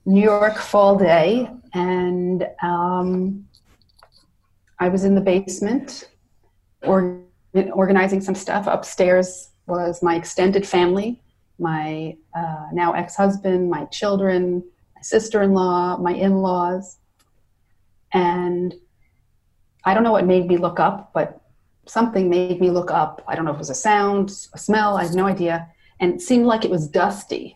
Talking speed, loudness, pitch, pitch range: 150 wpm, -20 LUFS, 180 Hz, 170-195 Hz